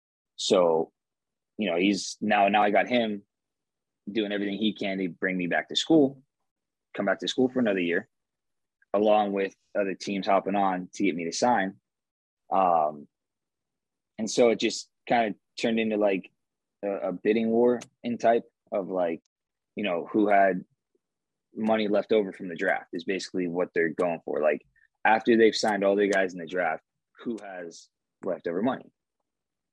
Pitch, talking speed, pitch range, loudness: 100 Hz, 170 wpm, 95-110 Hz, -26 LUFS